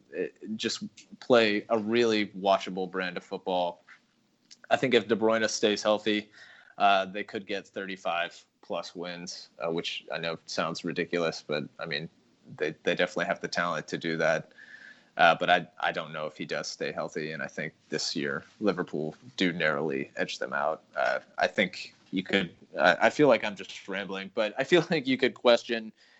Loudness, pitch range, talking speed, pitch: -29 LUFS, 95-120 Hz, 185 wpm, 105 Hz